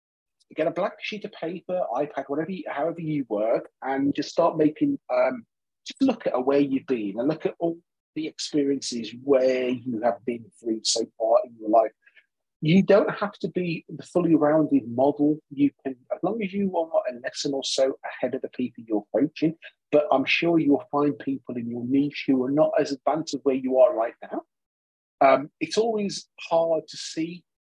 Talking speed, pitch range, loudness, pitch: 195 wpm, 135-175 Hz, -25 LUFS, 150 Hz